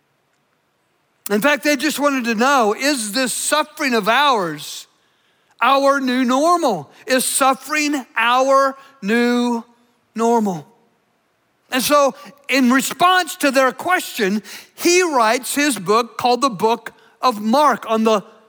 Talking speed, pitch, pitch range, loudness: 125 wpm, 255 Hz, 225-280 Hz, -17 LUFS